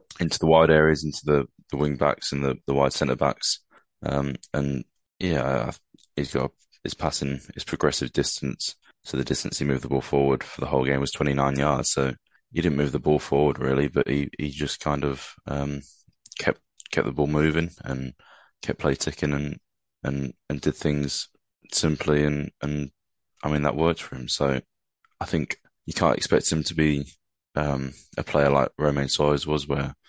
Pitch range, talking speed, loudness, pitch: 70-75 Hz, 195 wpm, -25 LUFS, 70 Hz